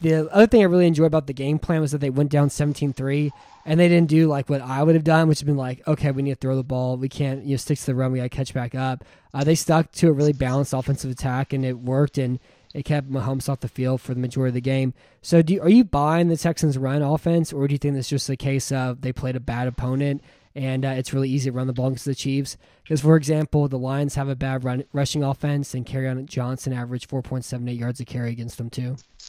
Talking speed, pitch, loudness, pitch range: 280 wpm, 135 Hz, -22 LUFS, 130-150 Hz